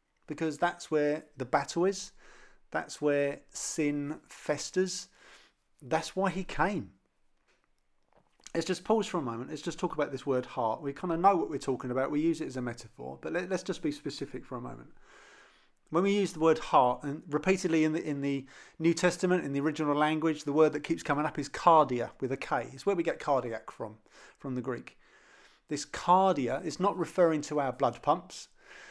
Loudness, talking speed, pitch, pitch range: -31 LUFS, 200 wpm, 155 Hz, 140-175 Hz